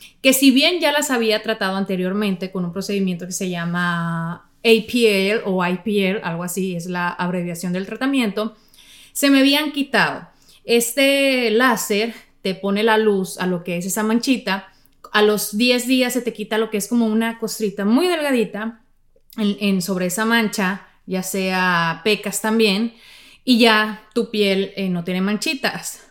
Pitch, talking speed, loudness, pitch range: 210 Hz, 165 wpm, -19 LUFS, 190-230 Hz